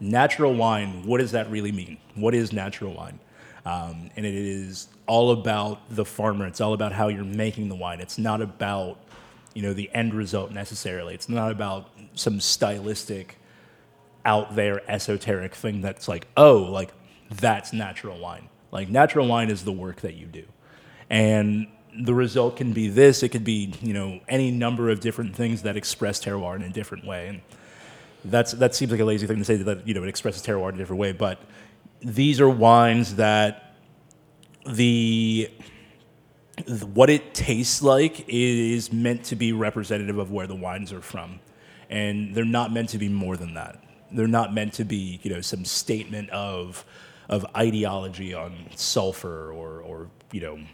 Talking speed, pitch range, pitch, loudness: 180 wpm, 100-115 Hz, 105 Hz, -24 LUFS